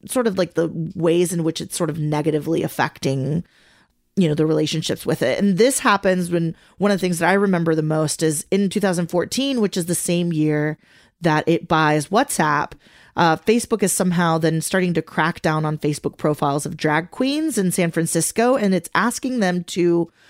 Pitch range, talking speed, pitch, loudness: 160-195 Hz, 195 wpm, 170 Hz, -20 LUFS